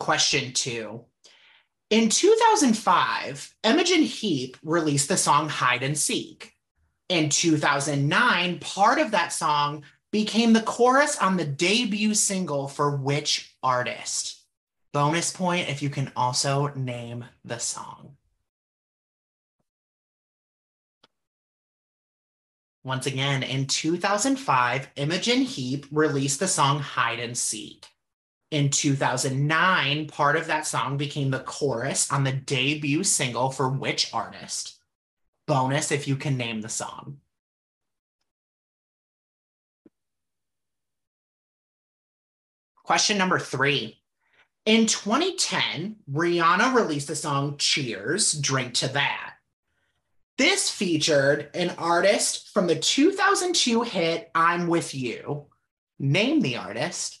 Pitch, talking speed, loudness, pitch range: 145 Hz, 105 wpm, -23 LUFS, 135-185 Hz